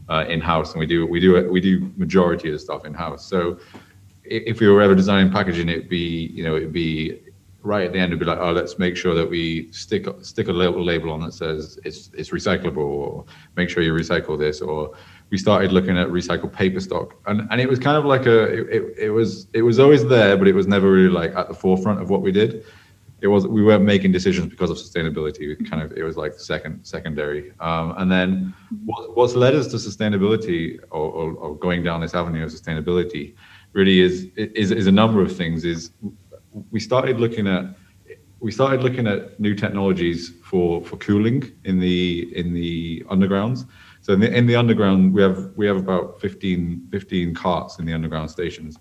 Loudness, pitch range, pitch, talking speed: -20 LUFS, 85-105 Hz, 95 Hz, 215 wpm